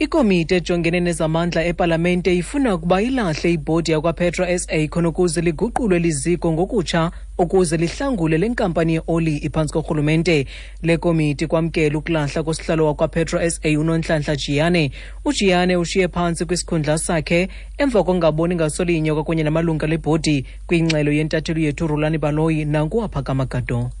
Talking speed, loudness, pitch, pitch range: 120 wpm, -19 LUFS, 165 Hz, 155-180 Hz